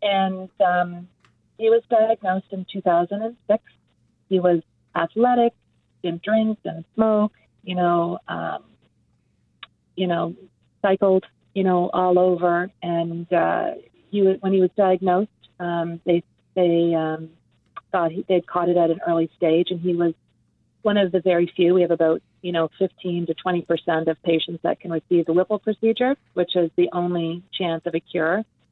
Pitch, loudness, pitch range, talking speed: 180 Hz, -22 LUFS, 170-195 Hz, 165 wpm